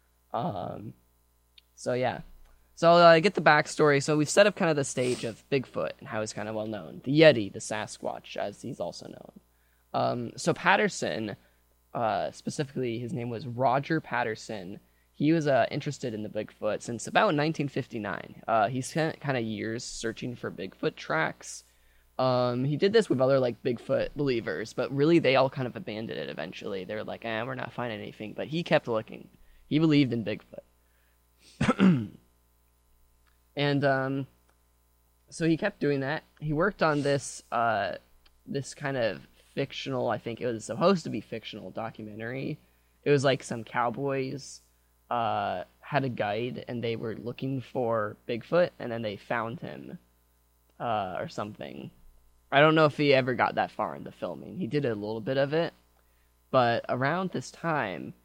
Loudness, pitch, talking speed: -28 LUFS, 120 Hz, 175 wpm